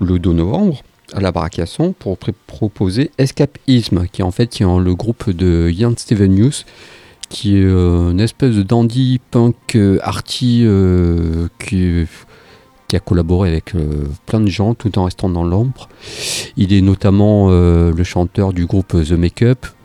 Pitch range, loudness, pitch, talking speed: 90-120 Hz, -15 LUFS, 100 Hz, 165 wpm